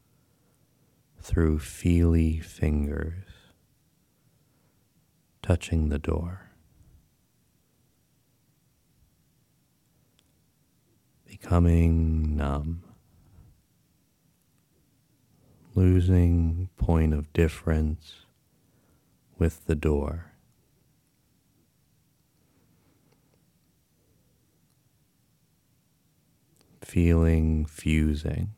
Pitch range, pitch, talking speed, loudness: 80-95 Hz, 85 Hz, 35 wpm, -26 LUFS